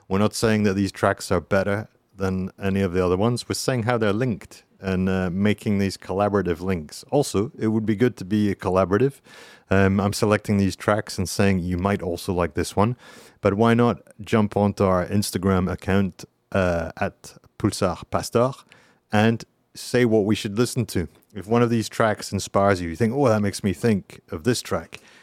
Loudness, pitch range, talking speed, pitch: -23 LUFS, 95-110 Hz, 195 wpm, 100 Hz